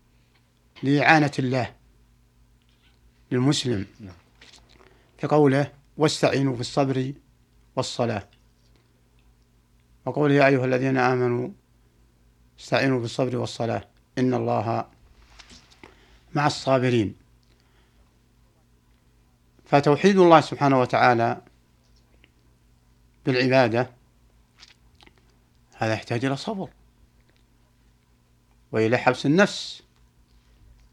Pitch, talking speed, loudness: 100 Hz, 60 wpm, -22 LUFS